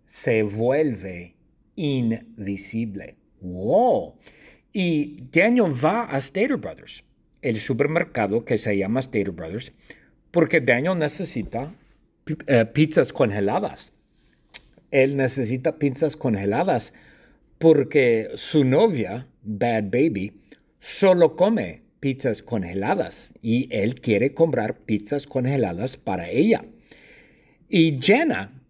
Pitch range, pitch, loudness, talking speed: 115-160 Hz, 135 Hz, -22 LUFS, 100 wpm